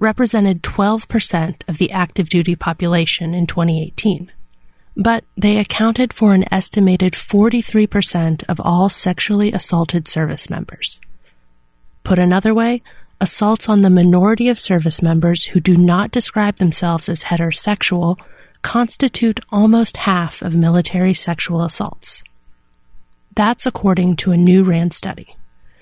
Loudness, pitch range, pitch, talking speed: -15 LUFS, 170-210 Hz, 180 Hz, 125 wpm